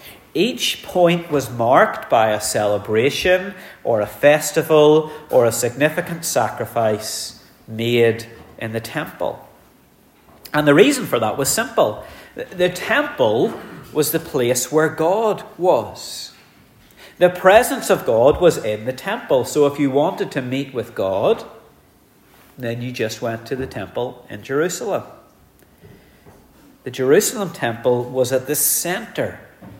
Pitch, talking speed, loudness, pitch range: 145 Hz, 130 wpm, -18 LUFS, 120-165 Hz